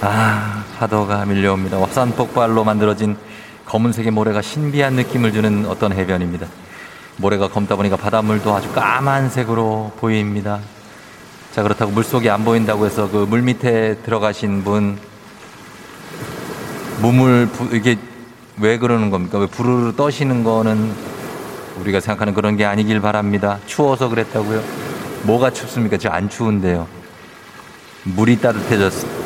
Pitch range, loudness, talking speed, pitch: 100-115 Hz, -17 LUFS, 310 characters per minute, 110 Hz